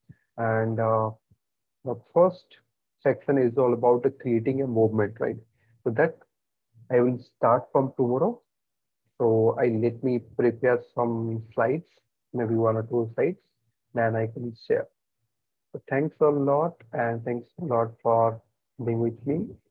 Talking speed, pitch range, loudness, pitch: 145 wpm, 115-125 Hz, -26 LUFS, 115 Hz